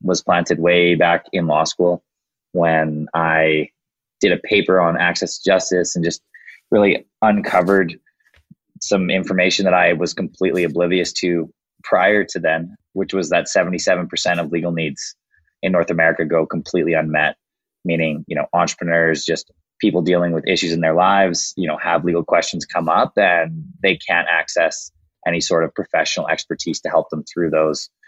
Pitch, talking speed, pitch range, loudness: 85 Hz, 165 wpm, 80-90 Hz, -18 LUFS